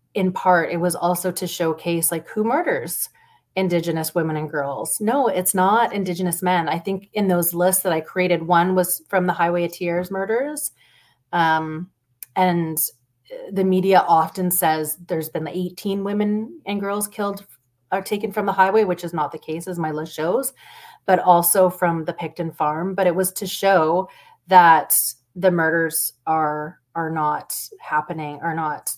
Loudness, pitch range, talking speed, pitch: -20 LUFS, 160-190 Hz, 170 wpm, 180 Hz